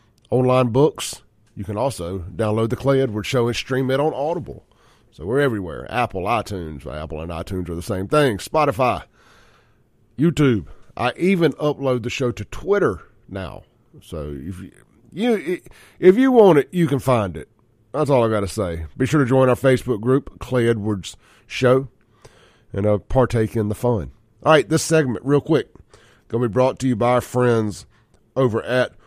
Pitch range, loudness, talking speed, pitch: 105-135 Hz, -20 LUFS, 180 wpm, 120 Hz